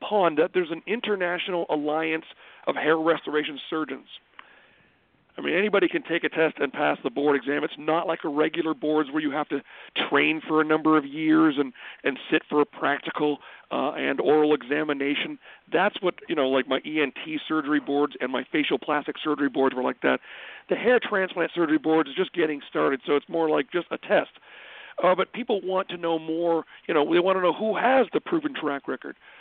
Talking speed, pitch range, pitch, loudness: 205 wpm, 150-175 Hz, 155 Hz, -25 LUFS